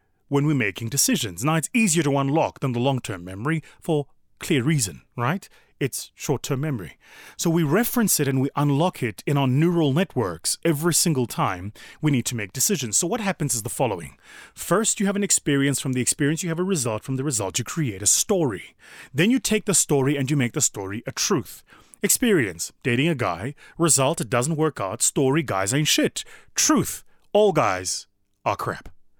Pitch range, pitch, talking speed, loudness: 120-165 Hz, 145 Hz, 195 wpm, -22 LUFS